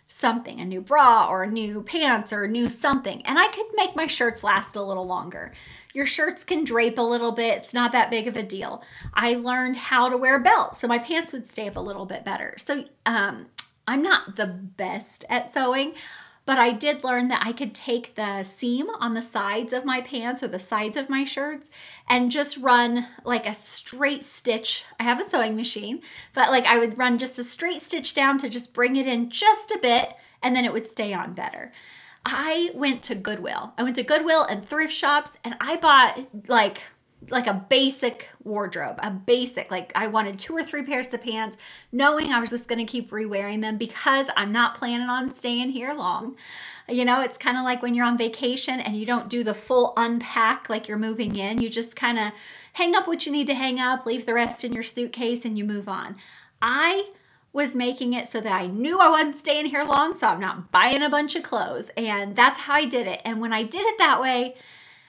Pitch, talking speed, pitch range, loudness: 245 Hz, 225 wpm, 225-280 Hz, -23 LUFS